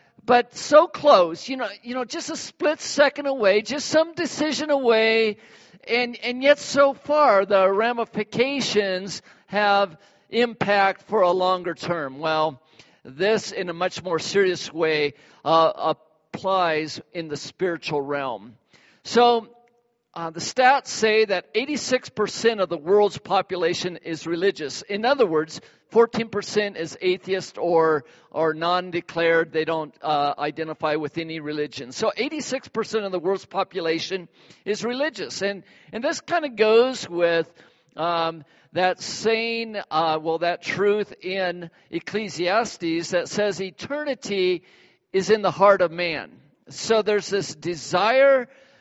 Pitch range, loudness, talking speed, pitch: 165-230 Hz, -23 LUFS, 135 wpm, 195 Hz